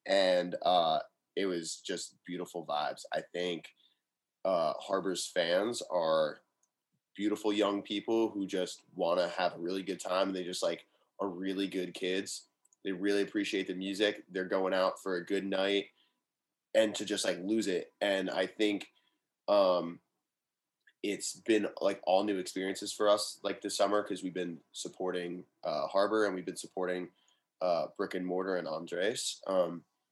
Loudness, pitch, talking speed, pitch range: -33 LUFS, 95 Hz, 165 wpm, 90-100 Hz